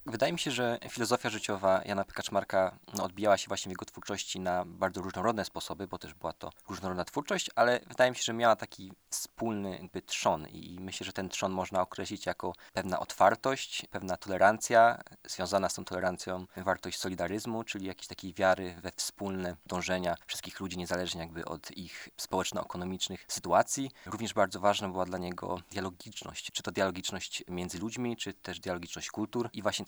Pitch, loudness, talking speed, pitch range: 95 Hz, -33 LUFS, 170 wpm, 90-110 Hz